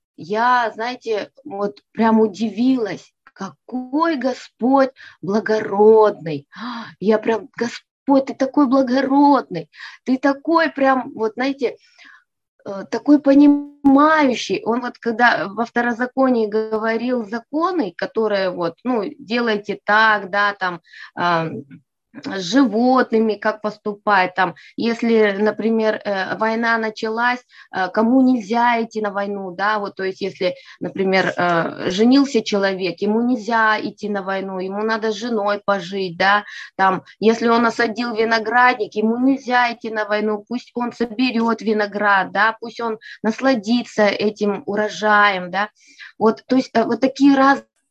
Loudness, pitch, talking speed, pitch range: -18 LUFS, 225 Hz, 120 wpm, 205-250 Hz